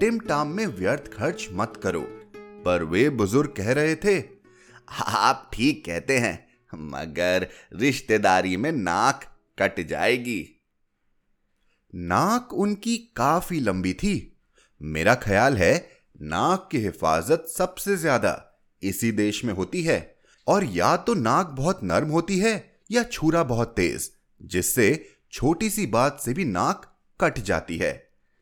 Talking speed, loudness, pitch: 130 wpm, -24 LUFS, 140 Hz